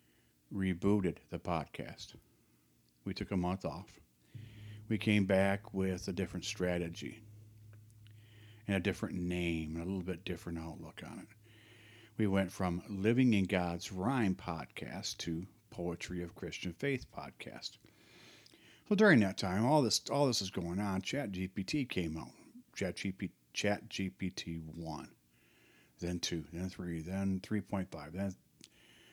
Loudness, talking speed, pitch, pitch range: -36 LUFS, 140 wpm, 95 Hz, 85-105 Hz